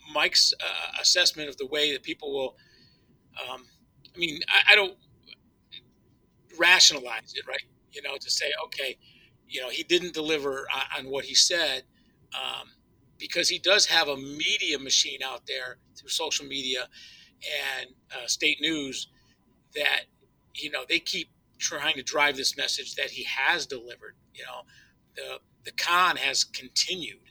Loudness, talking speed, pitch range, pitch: -25 LUFS, 155 wpm, 135-175 Hz, 150 Hz